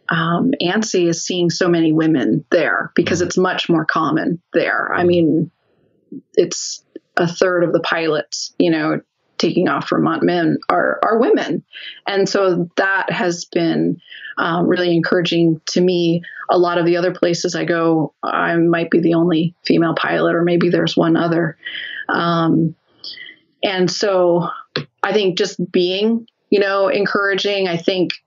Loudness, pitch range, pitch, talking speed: -17 LUFS, 170-185 Hz, 175 Hz, 155 wpm